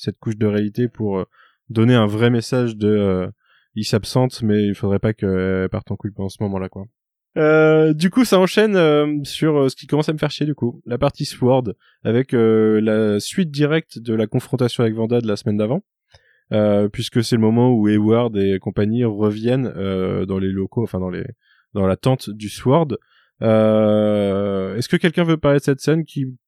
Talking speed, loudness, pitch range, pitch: 205 wpm, -18 LUFS, 105-135 Hz, 115 Hz